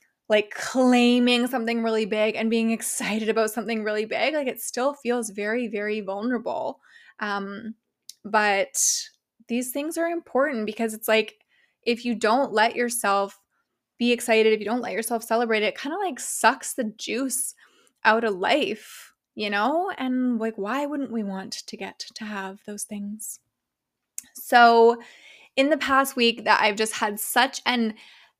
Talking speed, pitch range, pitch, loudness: 165 wpm, 215-255 Hz, 230 Hz, -24 LUFS